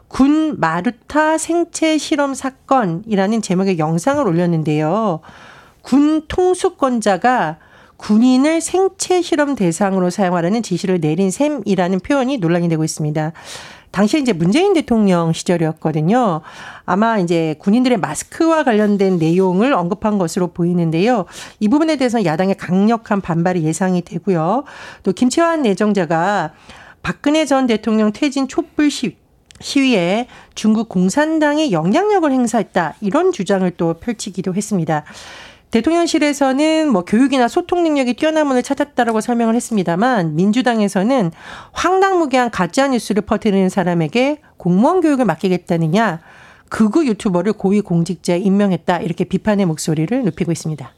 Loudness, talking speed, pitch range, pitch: -16 LUFS, 345 characters per minute, 180-275 Hz, 210 Hz